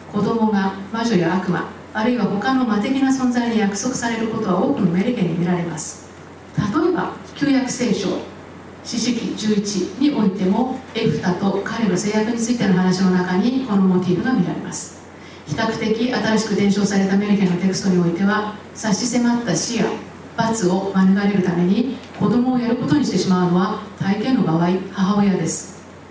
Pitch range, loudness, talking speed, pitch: 190-235 Hz, -19 LUFS, 360 characters per minute, 210 Hz